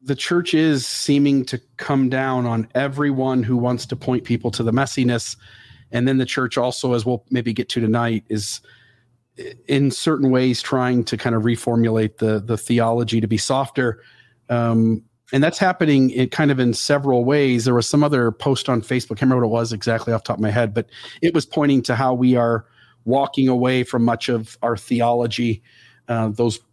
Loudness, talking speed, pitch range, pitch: -20 LUFS, 200 wpm, 115-130 Hz, 125 Hz